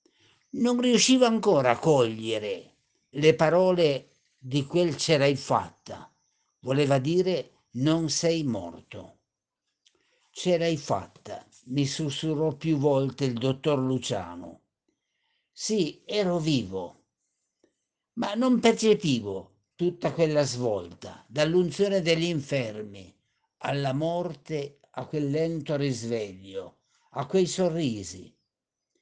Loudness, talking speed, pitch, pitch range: -26 LUFS, 100 wpm, 150 Hz, 130-175 Hz